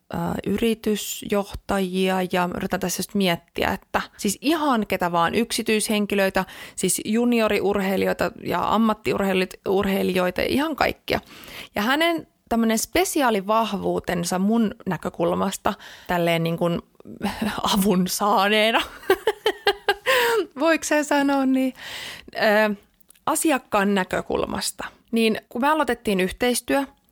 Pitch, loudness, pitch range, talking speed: 210 Hz, -22 LUFS, 190-265 Hz, 90 wpm